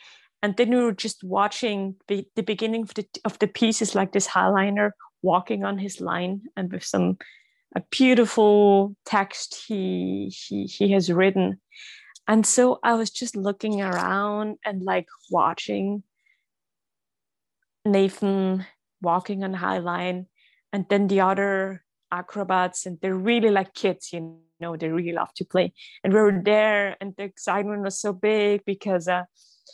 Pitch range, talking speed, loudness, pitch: 185-215 Hz, 150 wpm, -24 LUFS, 200 Hz